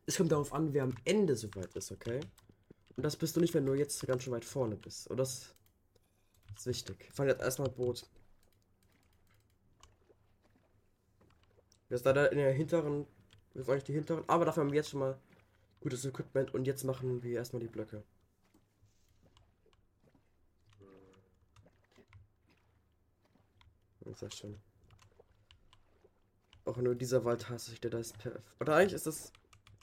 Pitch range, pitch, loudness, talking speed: 95-130 Hz, 105 Hz, -35 LUFS, 160 wpm